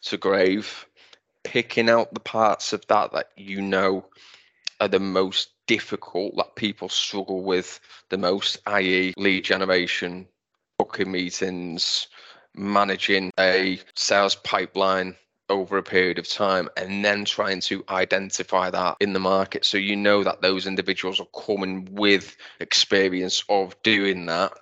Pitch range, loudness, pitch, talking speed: 95-100 Hz, -23 LUFS, 95 Hz, 140 wpm